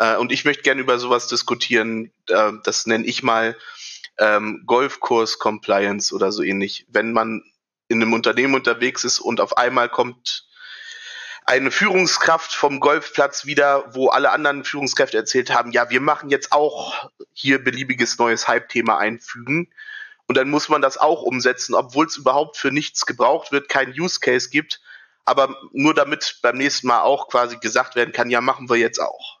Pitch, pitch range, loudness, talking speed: 125 Hz, 115-145 Hz, -19 LUFS, 170 wpm